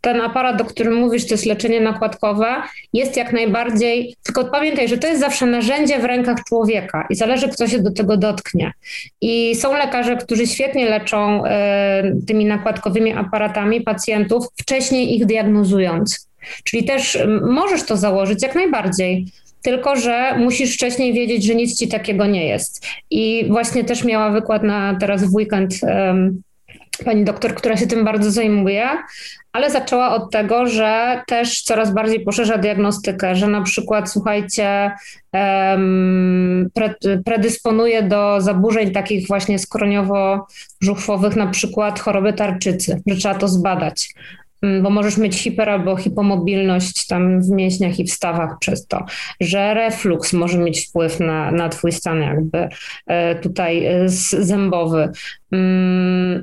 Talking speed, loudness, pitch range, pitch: 140 wpm, -17 LUFS, 195-230 Hz, 210 Hz